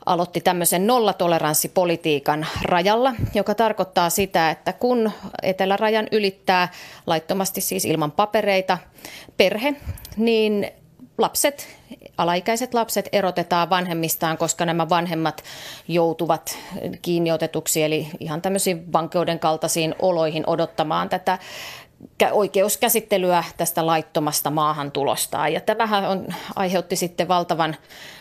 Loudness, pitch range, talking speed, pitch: -21 LUFS, 165-200 Hz, 95 wpm, 175 Hz